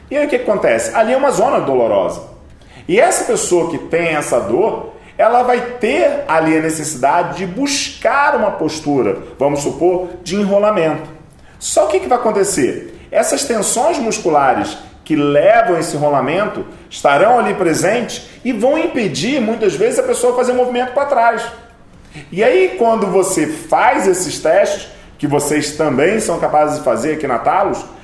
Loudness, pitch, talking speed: -15 LUFS, 200 Hz, 165 wpm